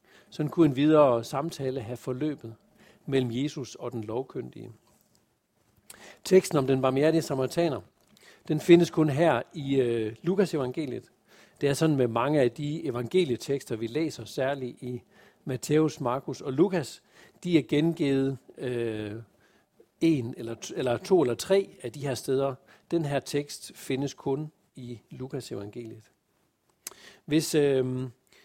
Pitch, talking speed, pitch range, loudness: 135 Hz, 140 wpm, 125-155 Hz, -27 LUFS